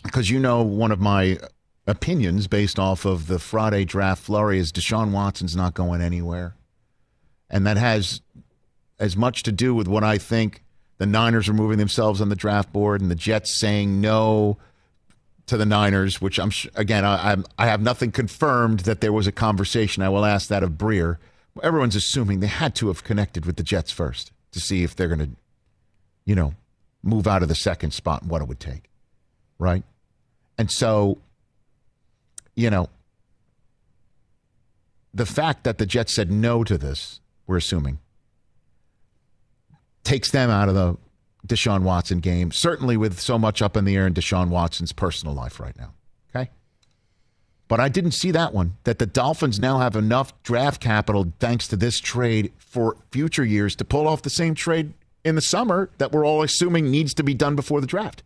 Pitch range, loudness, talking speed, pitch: 95-120 Hz, -22 LUFS, 185 wpm, 105 Hz